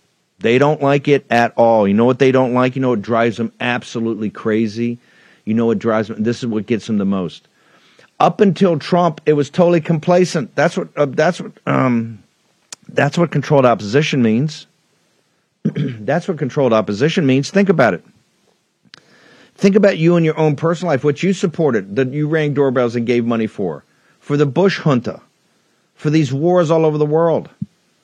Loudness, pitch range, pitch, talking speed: -16 LUFS, 120-165 Hz, 140 Hz, 185 wpm